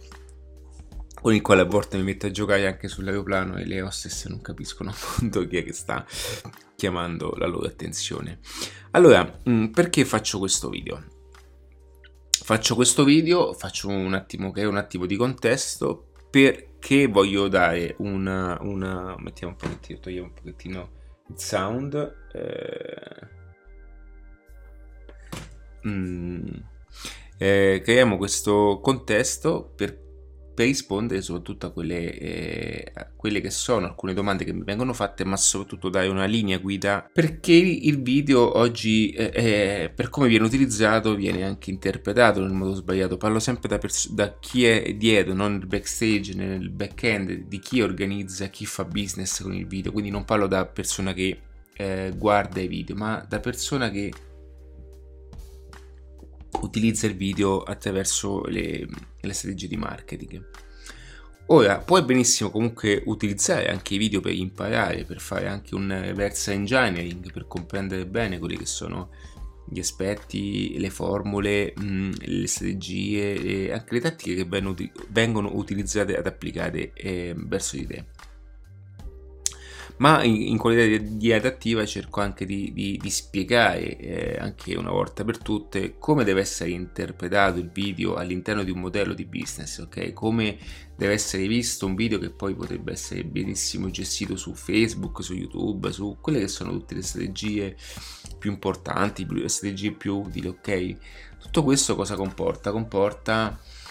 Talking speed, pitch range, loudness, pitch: 150 wpm, 90-110 Hz, -24 LUFS, 100 Hz